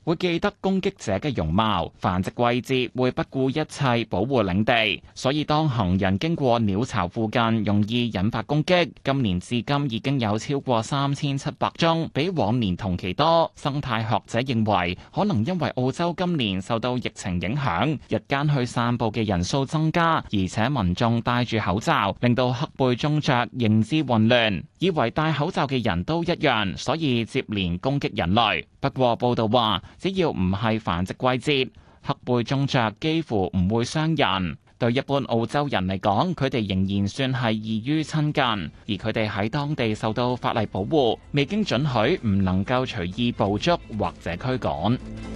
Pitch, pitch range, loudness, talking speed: 120 Hz, 105-145 Hz, -24 LUFS, 255 characters per minute